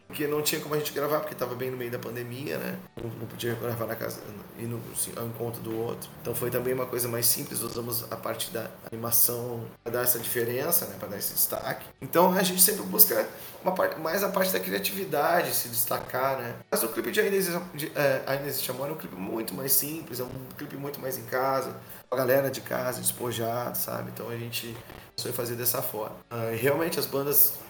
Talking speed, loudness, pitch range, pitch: 225 wpm, -27 LUFS, 115-145 Hz, 125 Hz